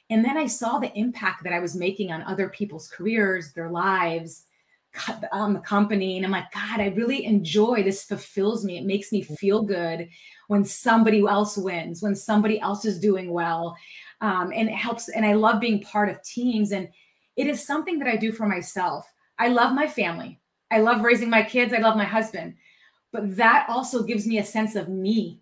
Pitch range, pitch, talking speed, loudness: 190-225 Hz, 210 Hz, 205 wpm, -24 LUFS